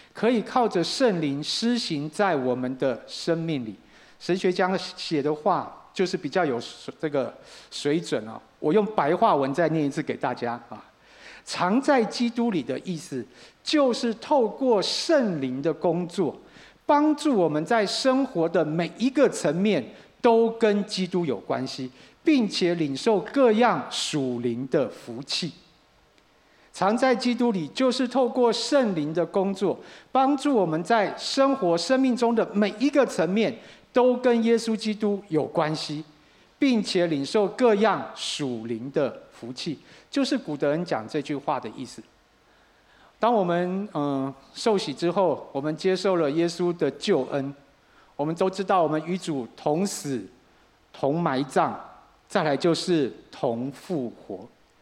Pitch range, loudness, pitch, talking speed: 150-230 Hz, -25 LUFS, 185 Hz, 210 characters per minute